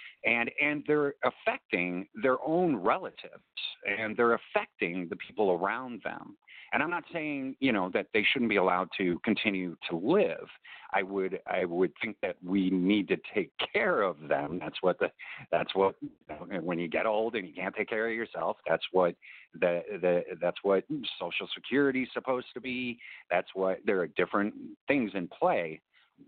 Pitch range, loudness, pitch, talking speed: 95-135 Hz, -30 LUFS, 110 Hz, 180 wpm